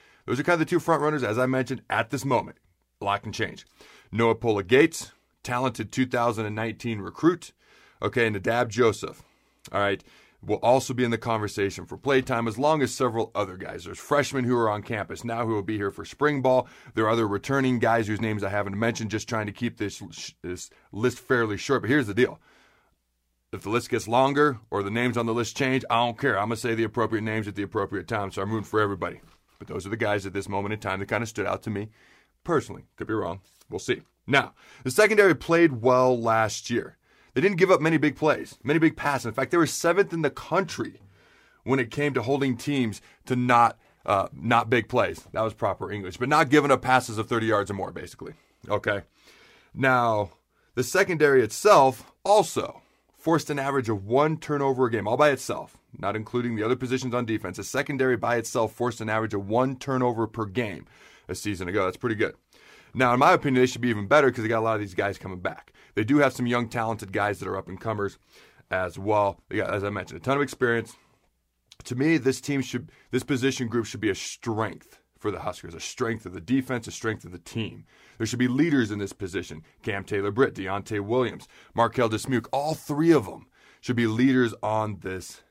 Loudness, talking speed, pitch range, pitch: -25 LUFS, 225 wpm, 105-130 Hz, 120 Hz